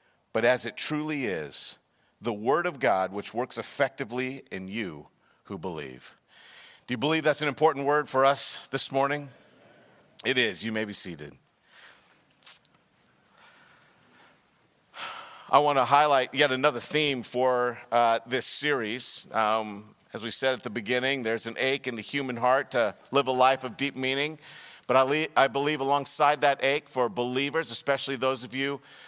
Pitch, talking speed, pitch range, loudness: 130 Hz, 165 wpm, 120-140 Hz, -27 LUFS